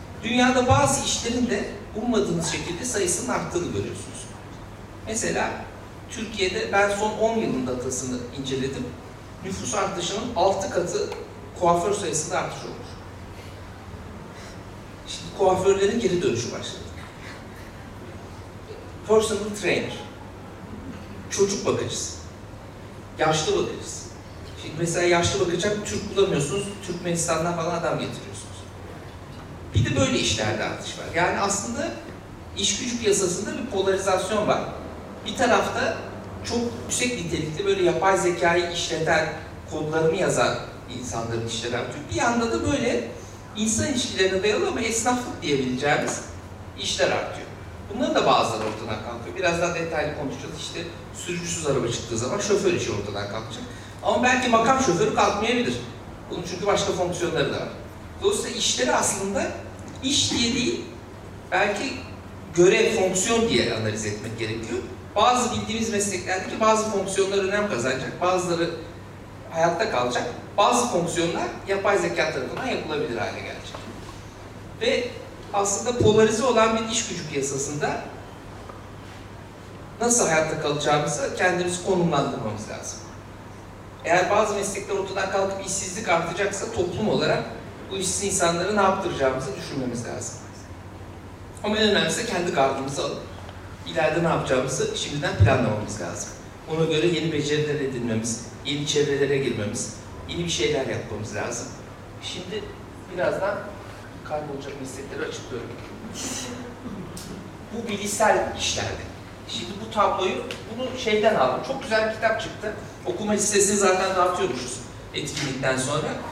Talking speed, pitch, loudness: 115 wpm, 140 Hz, -24 LUFS